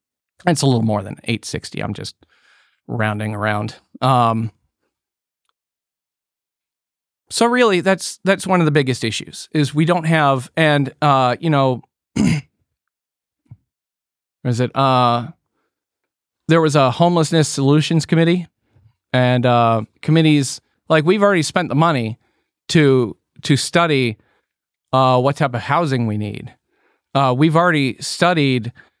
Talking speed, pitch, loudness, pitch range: 125 wpm, 135 Hz, -17 LUFS, 120-160 Hz